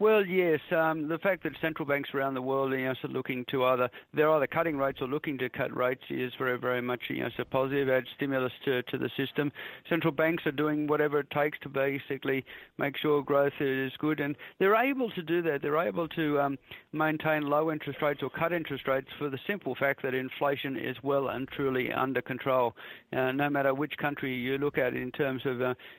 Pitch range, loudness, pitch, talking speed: 130-155 Hz, -30 LUFS, 140 Hz, 225 wpm